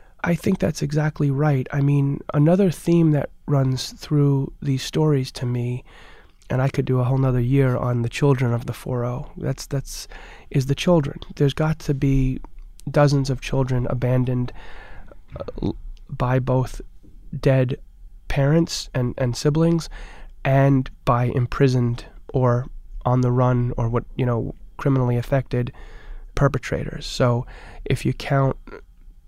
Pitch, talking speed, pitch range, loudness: 135 Hz, 140 wpm, 125-145 Hz, -22 LUFS